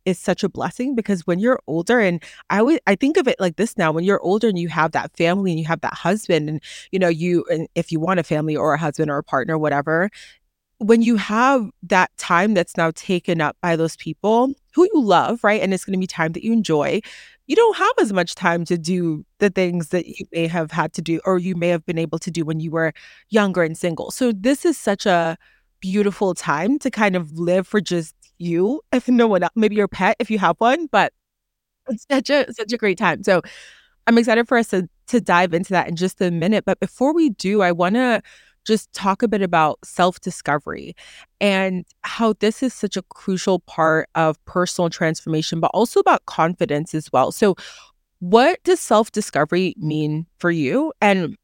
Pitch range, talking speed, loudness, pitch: 165-220 Hz, 220 wpm, -19 LUFS, 185 Hz